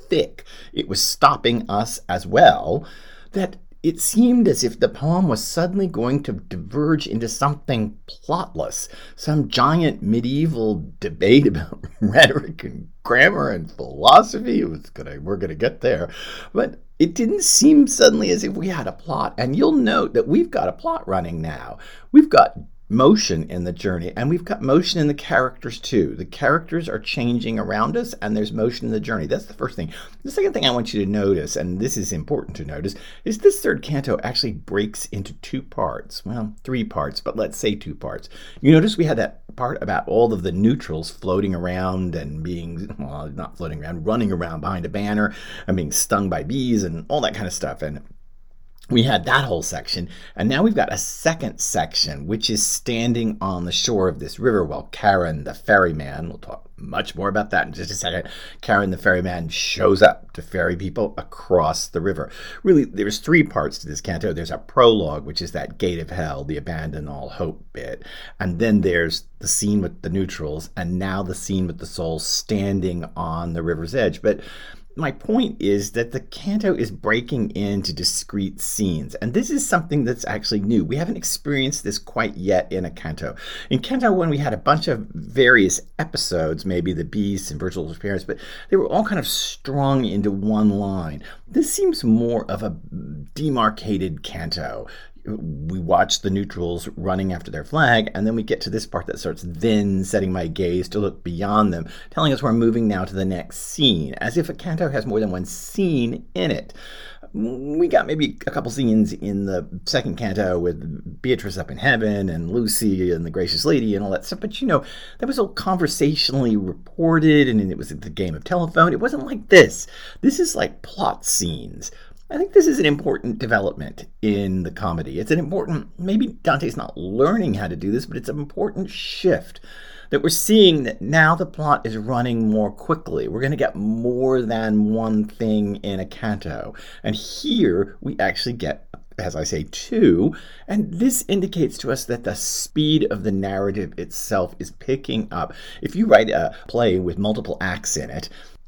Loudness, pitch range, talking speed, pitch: -20 LUFS, 95-150 Hz, 195 wpm, 110 Hz